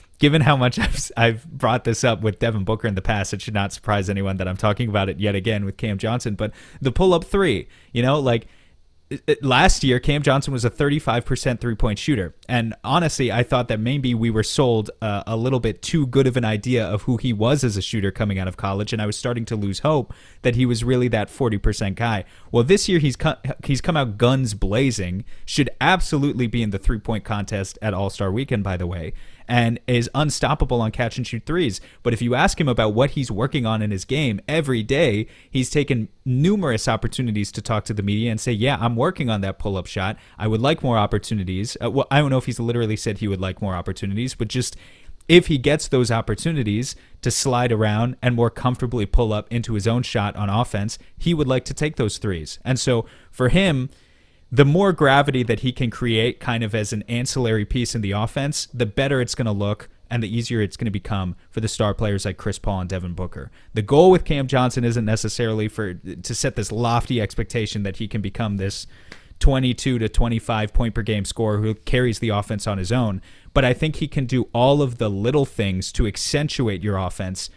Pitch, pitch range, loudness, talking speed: 115 Hz, 105-130 Hz, -21 LUFS, 225 wpm